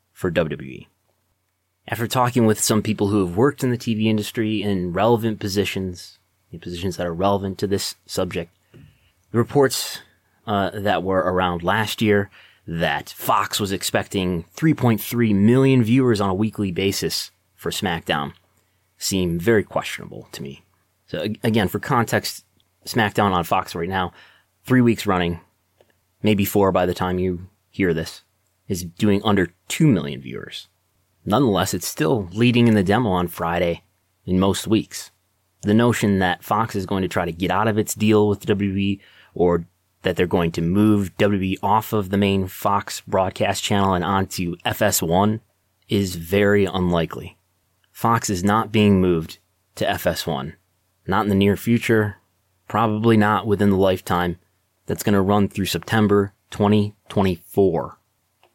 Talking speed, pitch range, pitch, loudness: 150 wpm, 90-105 Hz, 100 Hz, -21 LUFS